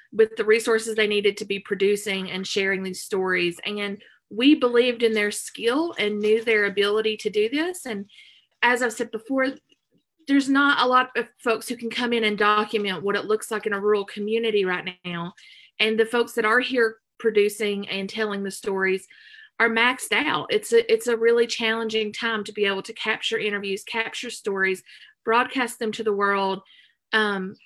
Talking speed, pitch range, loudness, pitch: 190 wpm, 205-240 Hz, -23 LUFS, 220 Hz